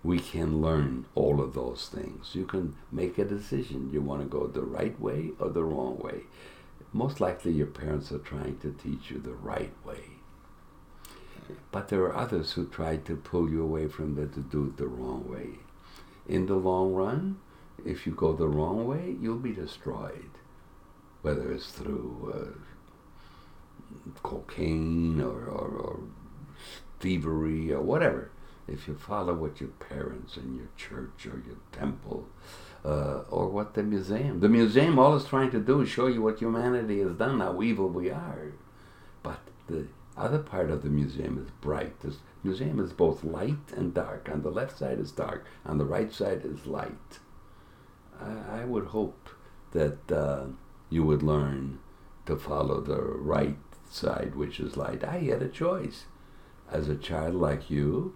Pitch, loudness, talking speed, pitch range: 80 Hz, -31 LUFS, 170 wpm, 75-100 Hz